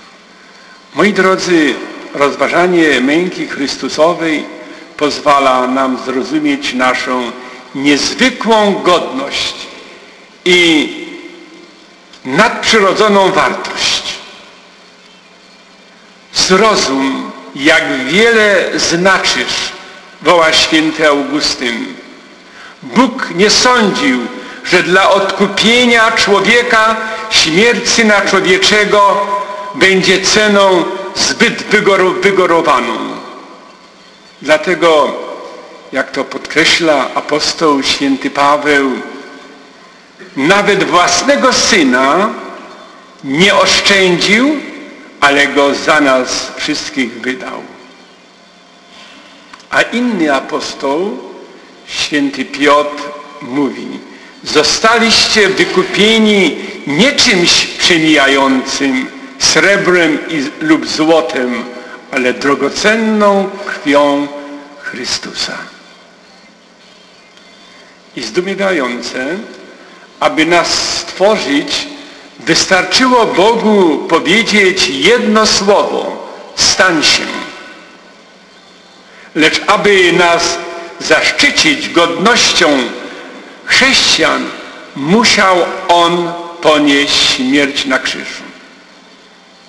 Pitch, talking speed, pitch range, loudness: 190 Hz, 65 wpm, 150-225 Hz, -10 LUFS